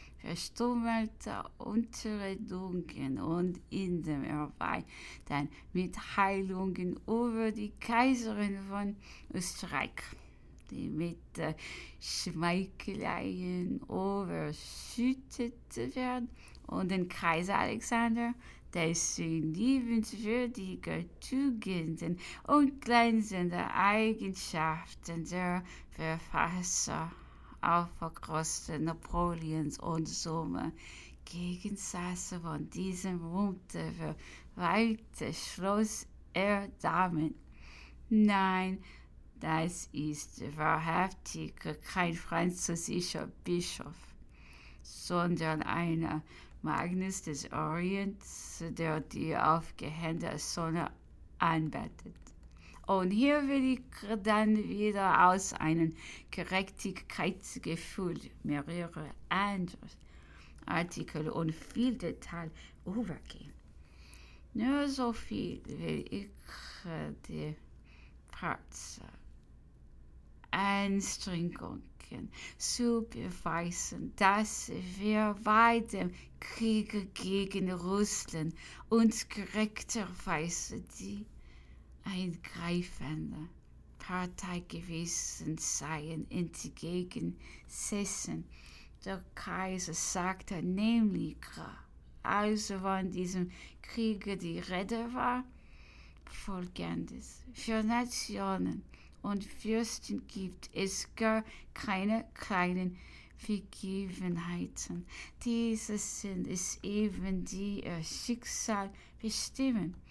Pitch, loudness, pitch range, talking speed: 180 Hz, -35 LUFS, 160-210 Hz, 75 wpm